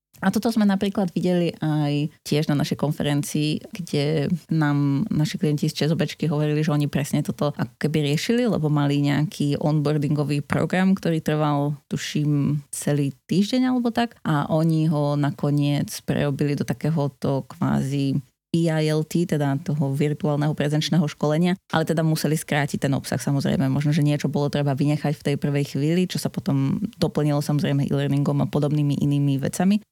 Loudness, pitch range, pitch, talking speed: -23 LUFS, 145-165 Hz, 150 Hz, 150 wpm